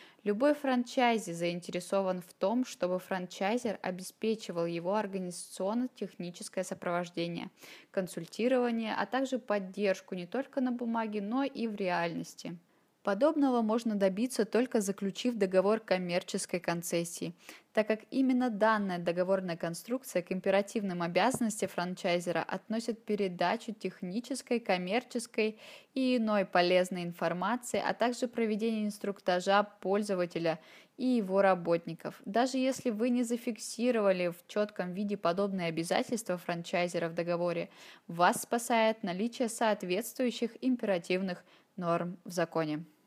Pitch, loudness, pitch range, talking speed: 200 Hz, -32 LUFS, 180-235 Hz, 110 wpm